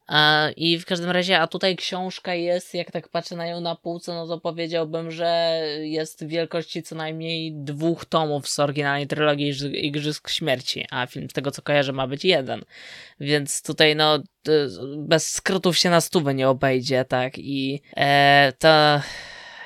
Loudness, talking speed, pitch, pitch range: -22 LUFS, 165 wpm, 155 Hz, 145-170 Hz